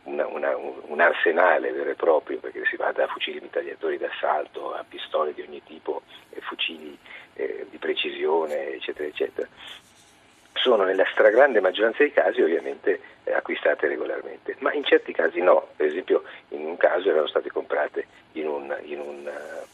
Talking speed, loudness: 160 wpm, -24 LUFS